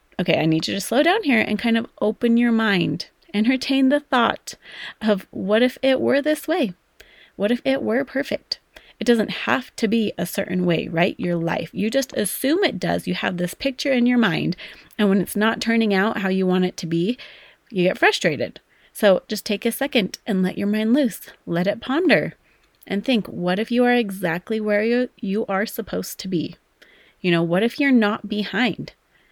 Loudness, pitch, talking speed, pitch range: -21 LUFS, 220 Hz, 205 wpm, 190-250 Hz